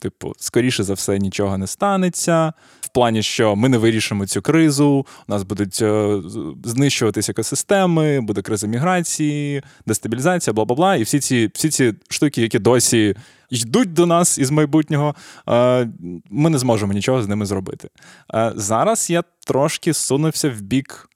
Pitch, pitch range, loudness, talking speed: 125 Hz, 110-155 Hz, -18 LUFS, 155 wpm